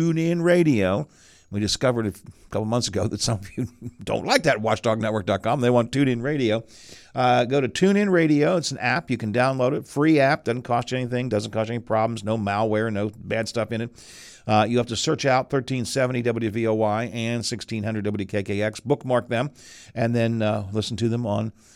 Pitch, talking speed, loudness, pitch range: 115 Hz, 200 wpm, -23 LUFS, 110-125 Hz